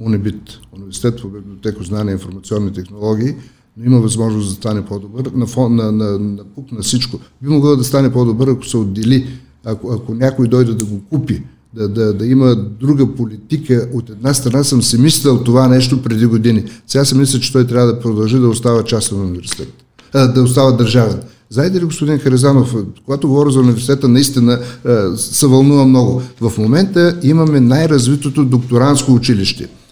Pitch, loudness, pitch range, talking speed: 125 Hz, -13 LUFS, 110-130 Hz, 175 wpm